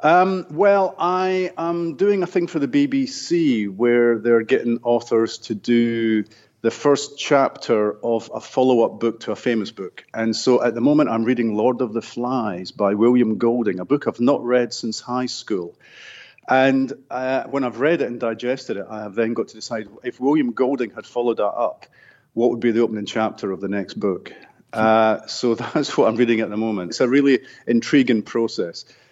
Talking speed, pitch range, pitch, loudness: 200 wpm, 115-140 Hz, 120 Hz, -20 LUFS